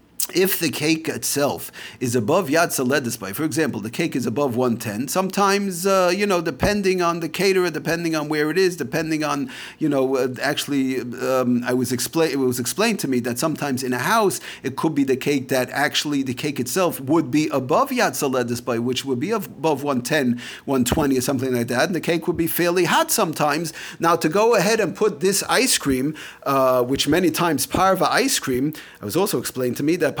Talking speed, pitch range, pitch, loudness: 210 wpm, 130-170 Hz, 150 Hz, -21 LUFS